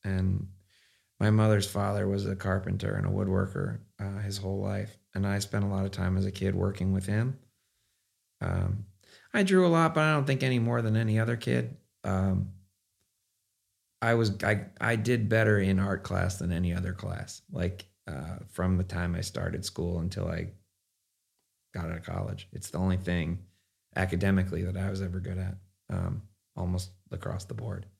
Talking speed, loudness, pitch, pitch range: 185 wpm, -30 LUFS, 100 Hz, 95-105 Hz